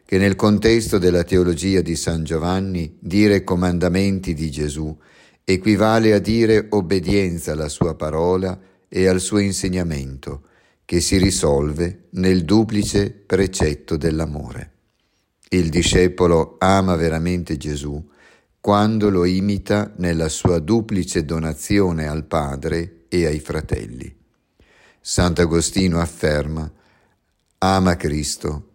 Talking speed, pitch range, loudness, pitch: 105 wpm, 80-95 Hz, -19 LUFS, 90 Hz